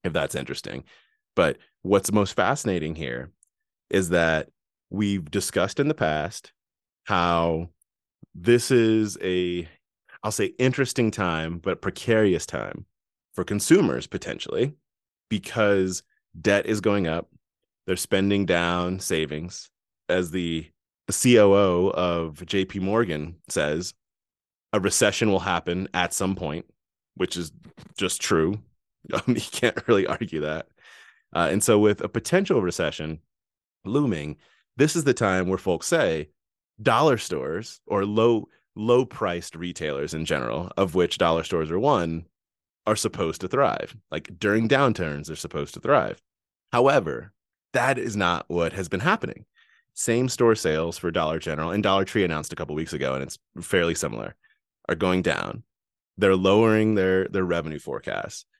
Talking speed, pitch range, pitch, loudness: 140 wpm, 85-105 Hz, 95 Hz, -24 LUFS